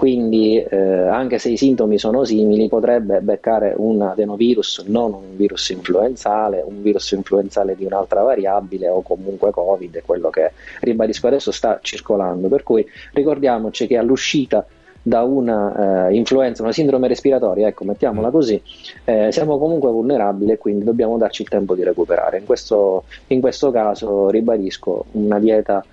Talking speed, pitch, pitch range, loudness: 155 wpm, 110 Hz, 100-125 Hz, -17 LUFS